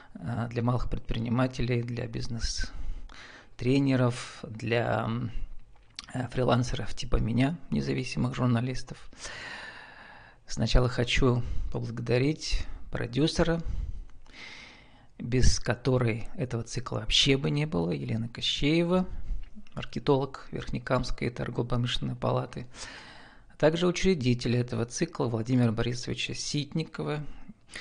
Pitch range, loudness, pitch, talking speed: 115-140 Hz, -29 LUFS, 125 Hz, 80 wpm